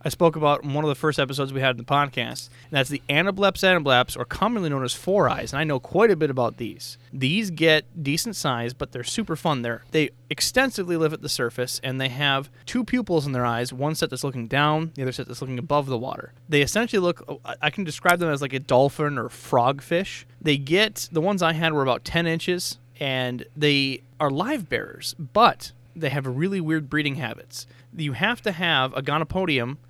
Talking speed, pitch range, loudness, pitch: 220 wpm, 130-165 Hz, -23 LUFS, 145 Hz